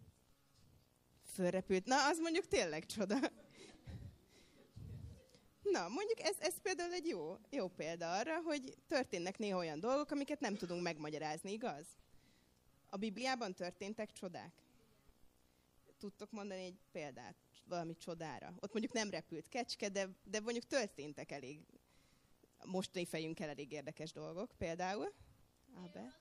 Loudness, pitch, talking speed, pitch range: -42 LUFS, 190 Hz, 120 wpm, 155-250 Hz